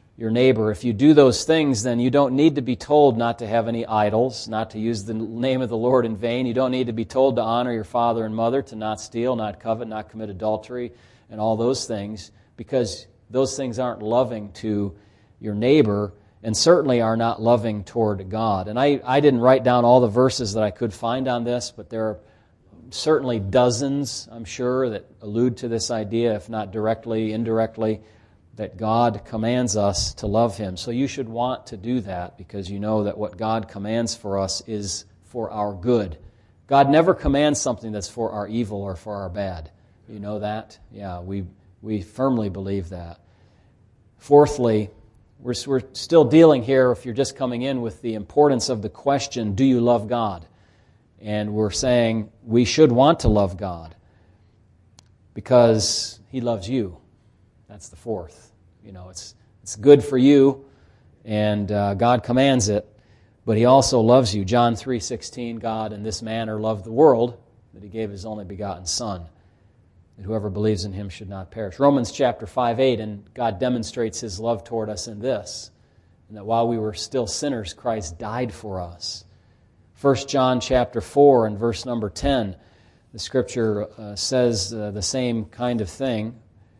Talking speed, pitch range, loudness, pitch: 185 wpm, 105-125 Hz, -21 LUFS, 110 Hz